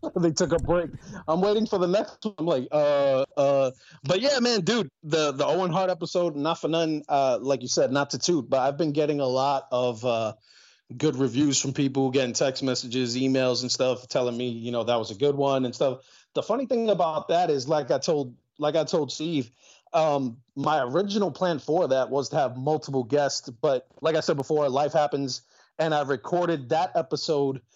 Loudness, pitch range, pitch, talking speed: -25 LUFS, 130-165 Hz, 145 Hz, 210 wpm